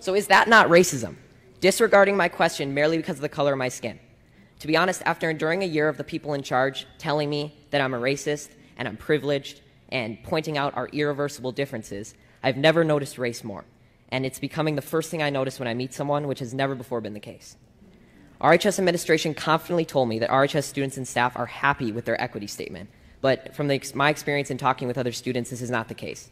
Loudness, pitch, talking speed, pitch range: -24 LUFS, 140 Hz, 225 wpm, 125-155 Hz